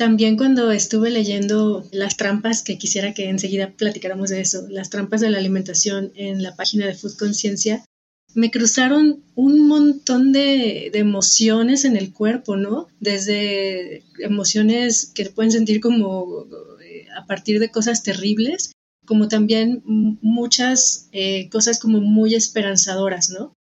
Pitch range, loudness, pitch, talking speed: 195-230 Hz, -18 LUFS, 215 Hz, 140 wpm